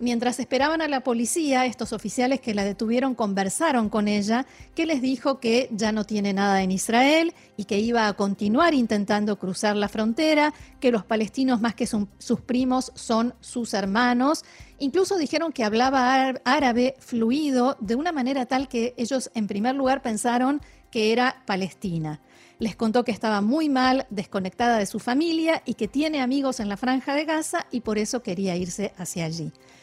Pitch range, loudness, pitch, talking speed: 215-265 Hz, -24 LUFS, 240 Hz, 175 wpm